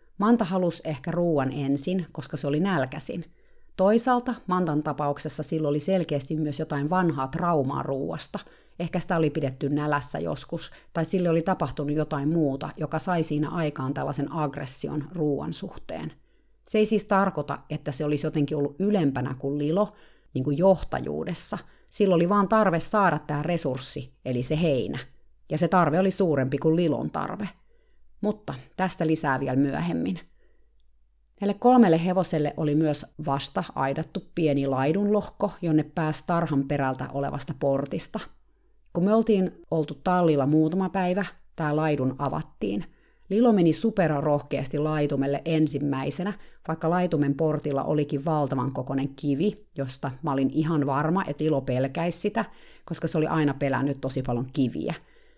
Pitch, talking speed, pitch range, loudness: 155 Hz, 145 wpm, 140-180 Hz, -26 LUFS